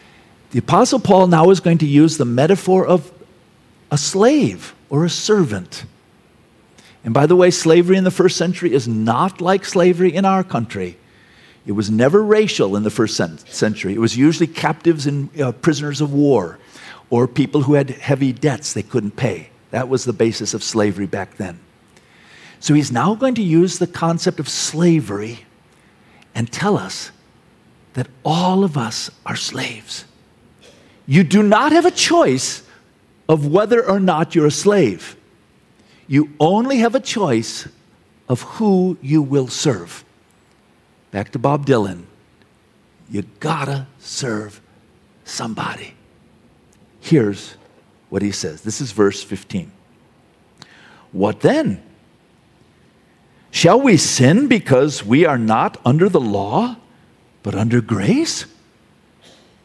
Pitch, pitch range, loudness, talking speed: 145 Hz, 115-180 Hz, -16 LUFS, 140 wpm